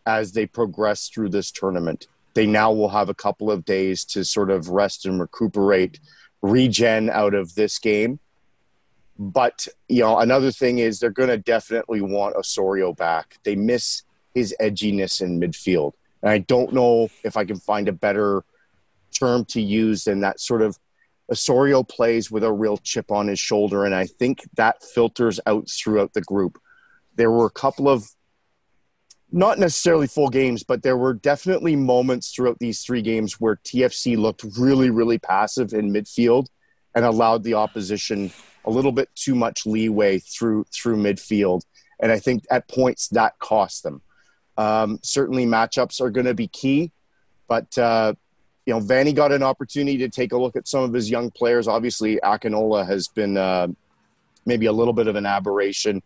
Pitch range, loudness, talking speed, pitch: 105-125 Hz, -21 LUFS, 175 wpm, 110 Hz